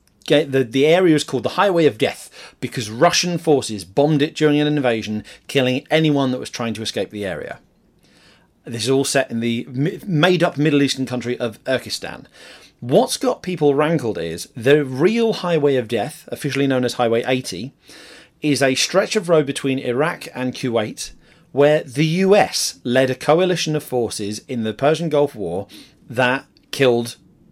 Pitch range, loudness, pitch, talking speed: 125-155 Hz, -19 LUFS, 135 Hz, 170 wpm